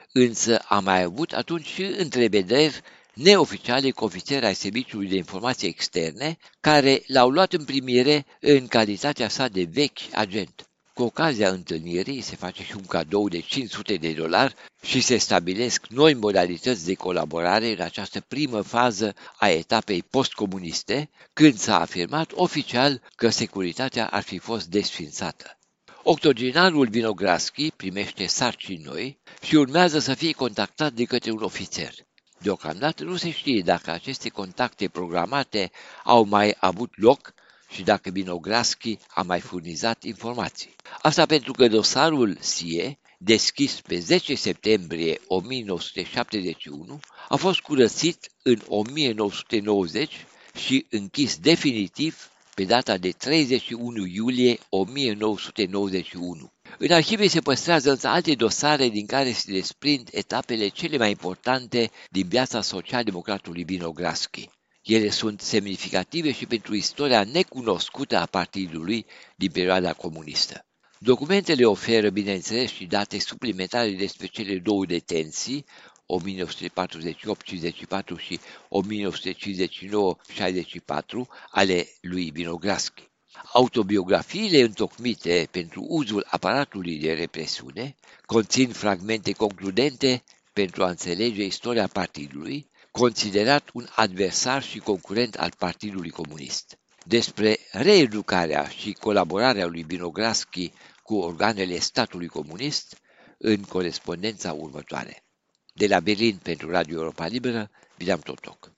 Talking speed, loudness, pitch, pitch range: 115 wpm, -24 LUFS, 105 Hz, 95-130 Hz